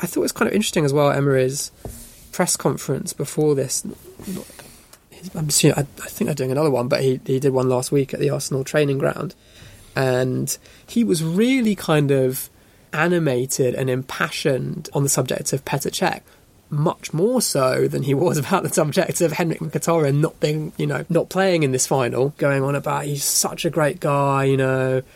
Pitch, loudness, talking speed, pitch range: 140 Hz, -20 LUFS, 195 wpm, 130-165 Hz